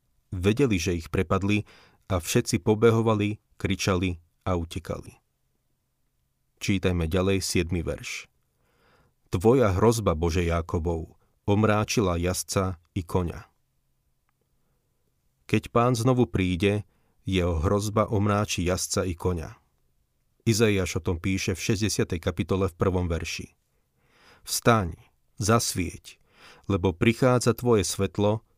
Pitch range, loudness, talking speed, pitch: 90-110 Hz, -26 LUFS, 100 wpm, 95 Hz